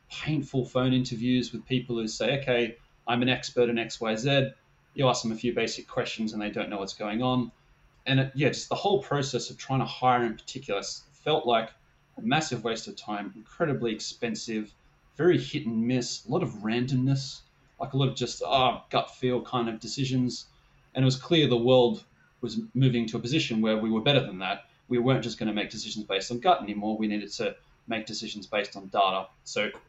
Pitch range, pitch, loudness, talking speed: 110-130 Hz, 120 Hz, -28 LUFS, 210 wpm